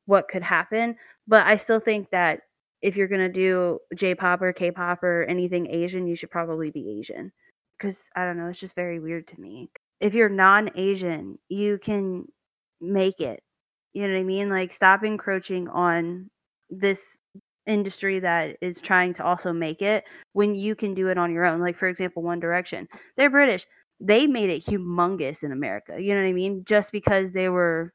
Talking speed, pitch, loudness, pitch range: 200 wpm, 185 Hz, -24 LUFS, 175-200 Hz